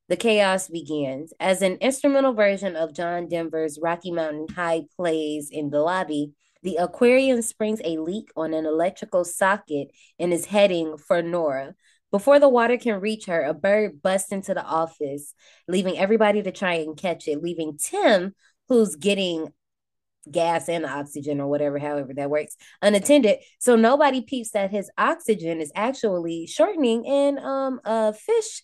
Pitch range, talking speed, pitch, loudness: 160-220 Hz, 160 wpm, 180 Hz, -23 LUFS